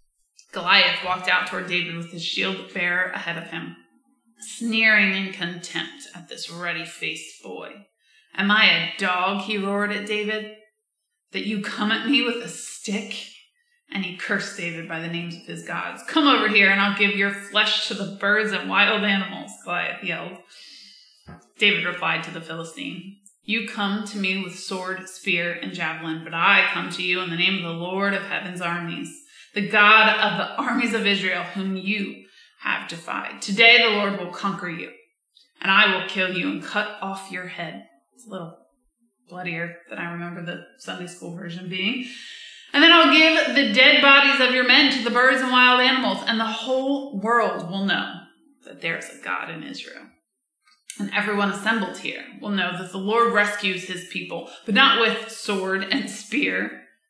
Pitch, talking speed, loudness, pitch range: 200 Hz, 185 wpm, -20 LUFS, 180-230 Hz